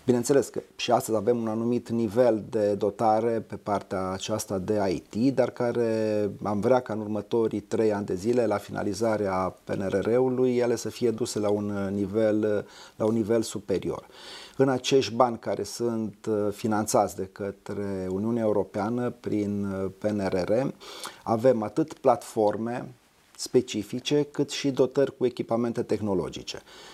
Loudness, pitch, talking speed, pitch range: -27 LUFS, 110 Hz, 140 wpm, 105-120 Hz